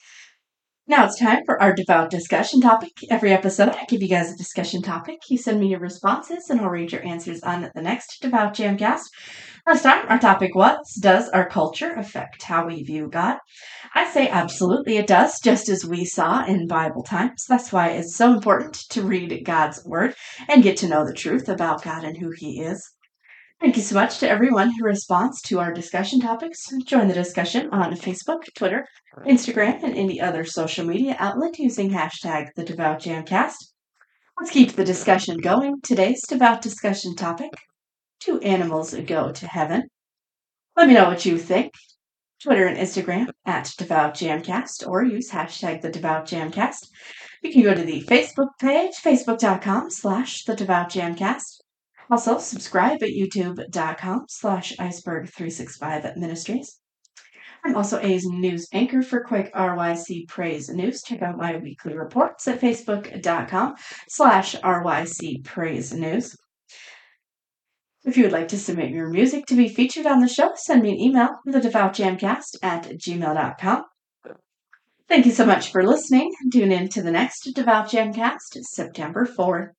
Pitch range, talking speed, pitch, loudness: 175-245 Hz, 160 wpm, 195 Hz, -21 LUFS